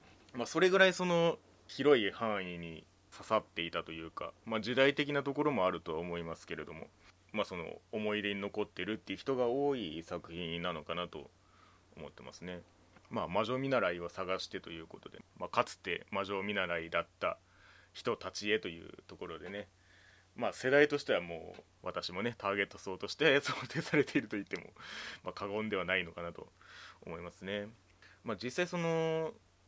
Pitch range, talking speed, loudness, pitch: 90-130 Hz, 360 characters per minute, -35 LUFS, 100 Hz